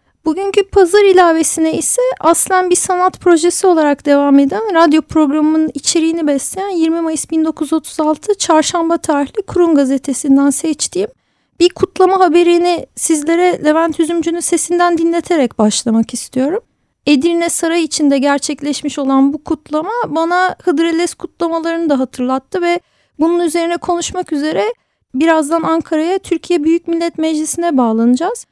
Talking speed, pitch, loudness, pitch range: 120 wpm, 330 Hz, -13 LUFS, 300-350 Hz